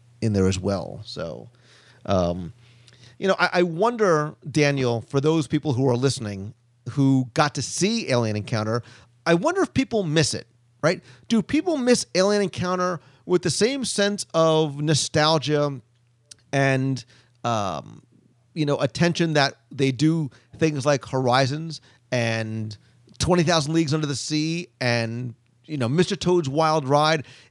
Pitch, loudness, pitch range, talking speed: 140 Hz, -23 LUFS, 120-165 Hz, 145 wpm